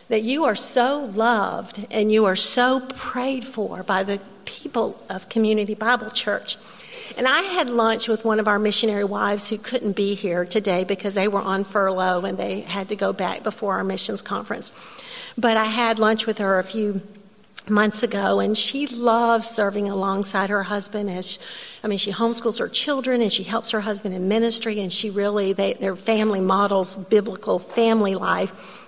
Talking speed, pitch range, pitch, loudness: 185 wpm, 200-230 Hz, 210 Hz, -21 LUFS